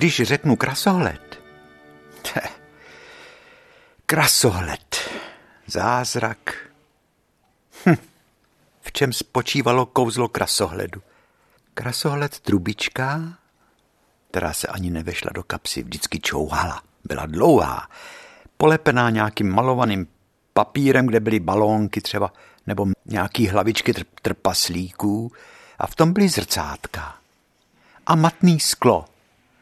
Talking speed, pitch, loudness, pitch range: 90 wpm, 115 Hz, -21 LUFS, 95-145 Hz